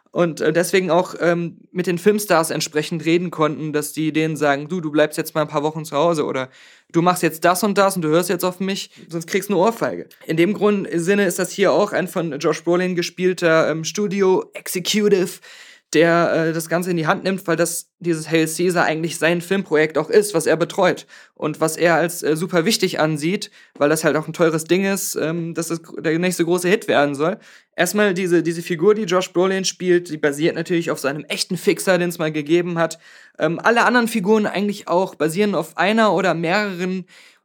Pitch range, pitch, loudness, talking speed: 160-190 Hz, 170 Hz, -19 LUFS, 220 wpm